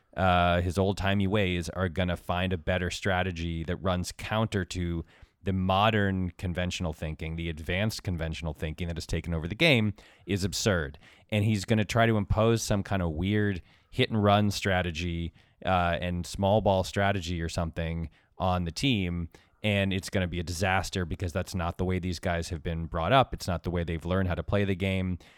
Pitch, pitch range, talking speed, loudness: 90 Hz, 85-100 Hz, 205 wpm, -29 LUFS